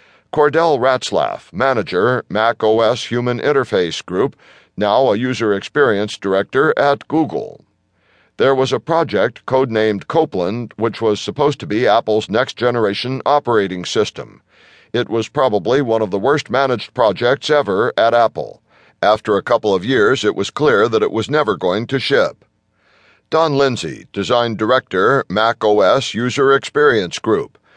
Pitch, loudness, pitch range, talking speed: 125 Hz, -16 LUFS, 110-145 Hz, 145 wpm